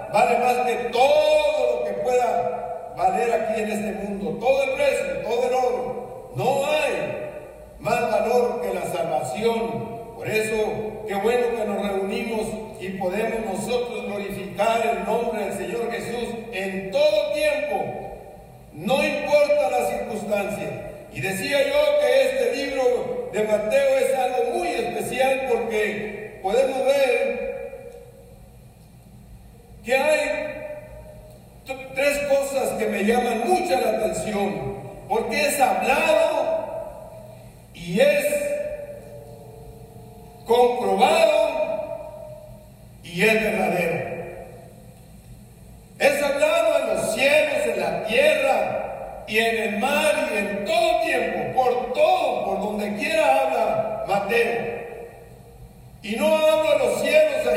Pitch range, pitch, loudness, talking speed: 210-290 Hz, 235 Hz, -22 LUFS, 115 wpm